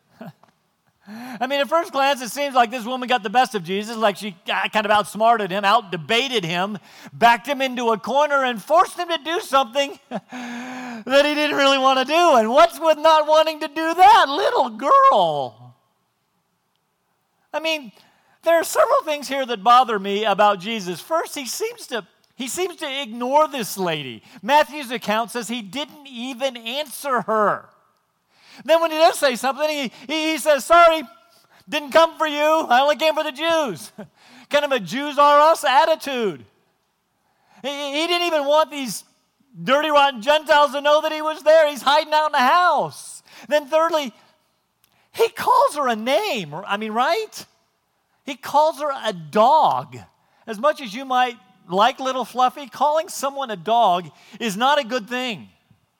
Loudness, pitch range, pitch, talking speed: -19 LUFS, 230-310 Hz, 275 Hz, 175 wpm